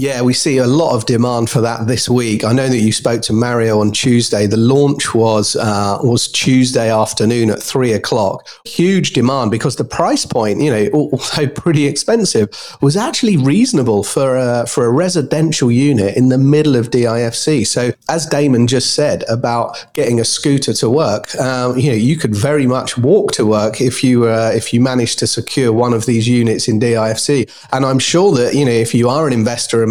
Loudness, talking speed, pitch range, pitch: -13 LUFS, 205 wpm, 115-140 Hz, 125 Hz